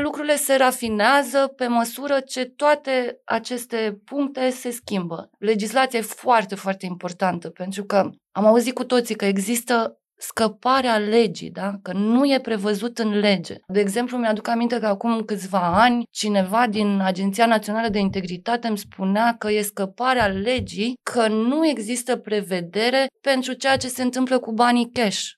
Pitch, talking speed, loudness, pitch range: 230 Hz, 155 wpm, -21 LUFS, 205-250 Hz